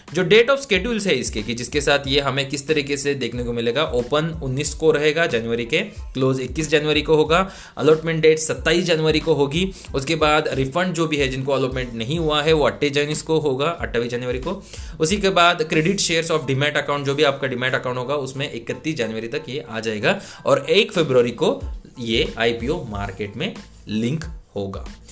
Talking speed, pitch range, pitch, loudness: 200 wpm, 125-160 Hz, 145 Hz, -20 LUFS